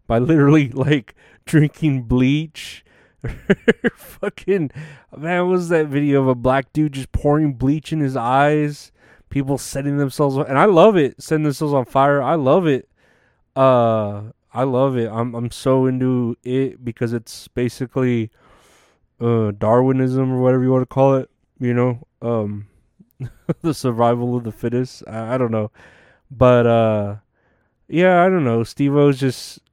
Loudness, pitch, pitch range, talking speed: -18 LUFS, 130 Hz, 120-145 Hz, 155 wpm